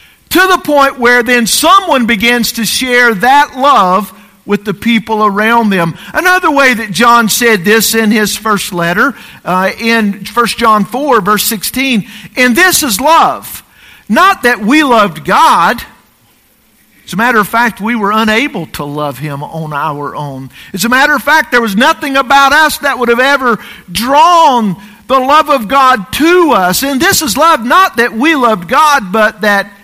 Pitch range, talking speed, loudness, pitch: 205-275 Hz, 175 wpm, -8 LUFS, 235 Hz